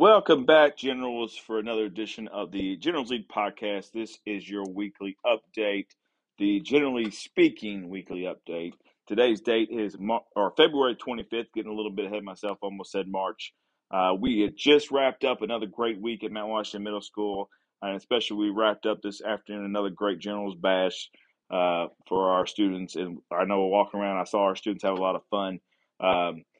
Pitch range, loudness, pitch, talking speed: 95-110 Hz, -27 LUFS, 105 Hz, 185 wpm